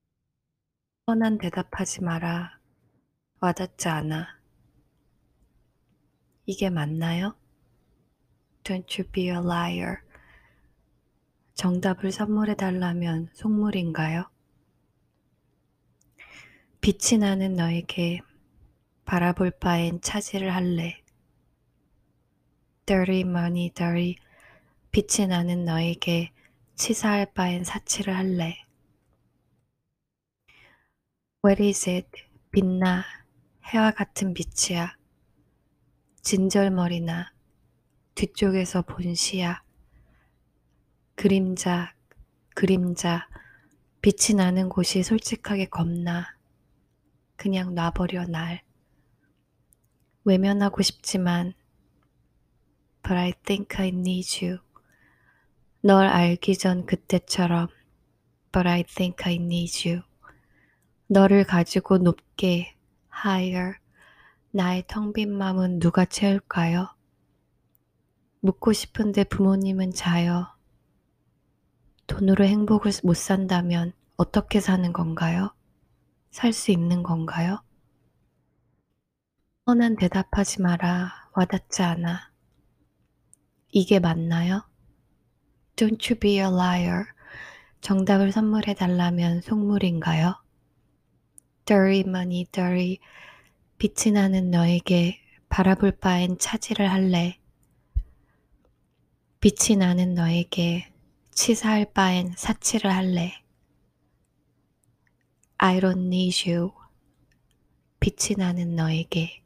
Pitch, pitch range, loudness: 180 Hz, 170-195 Hz, -24 LUFS